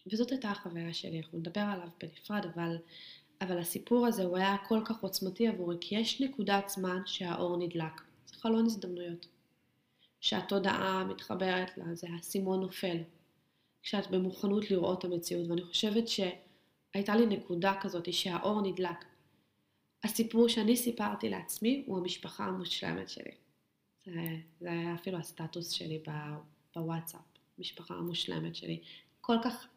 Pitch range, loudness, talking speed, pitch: 170-200 Hz, -35 LUFS, 135 wpm, 185 Hz